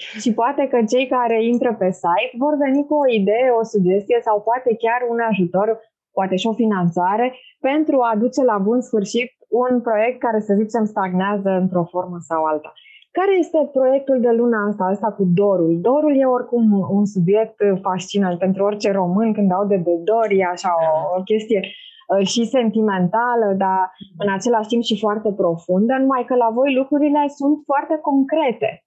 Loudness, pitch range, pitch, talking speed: -18 LUFS, 195-250 Hz, 220 Hz, 175 wpm